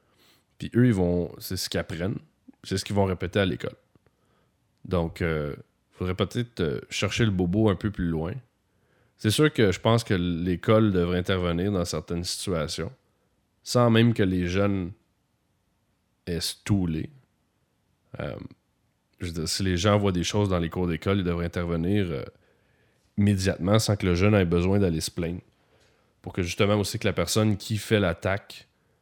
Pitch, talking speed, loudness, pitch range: 95 Hz, 175 wpm, -26 LUFS, 90-105 Hz